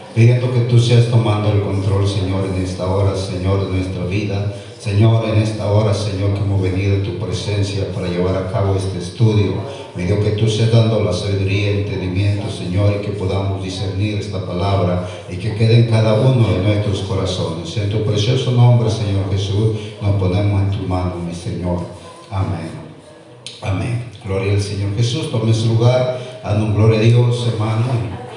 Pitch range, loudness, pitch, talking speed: 95-115 Hz, -17 LUFS, 100 Hz, 180 wpm